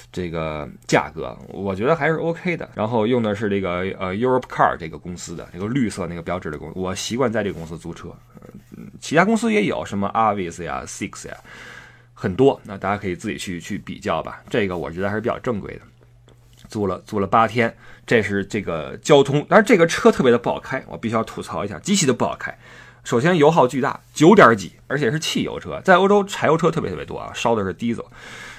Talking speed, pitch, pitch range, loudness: 365 characters per minute, 110 Hz, 95-140 Hz, -20 LUFS